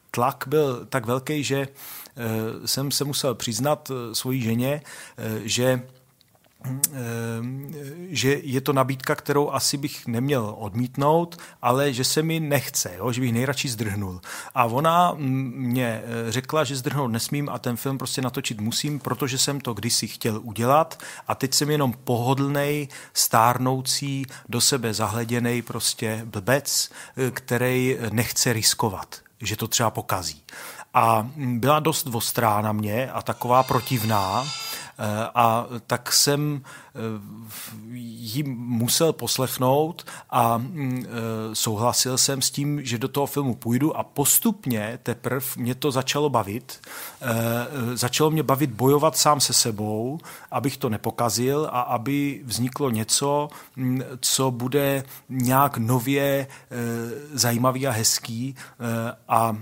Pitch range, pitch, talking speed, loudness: 115-140 Hz, 130 Hz, 120 wpm, -23 LUFS